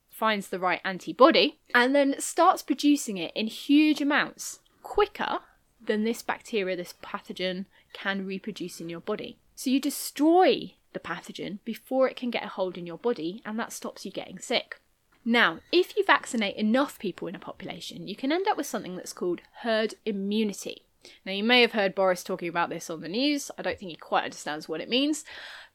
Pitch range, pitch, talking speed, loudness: 190-275 Hz, 220 Hz, 195 wpm, -27 LUFS